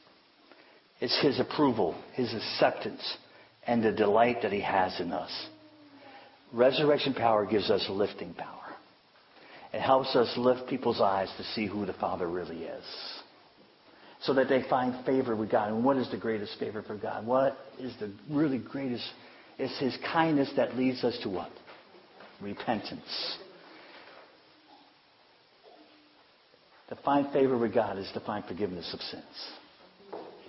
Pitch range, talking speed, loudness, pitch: 115-140 Hz, 140 wpm, -30 LUFS, 130 Hz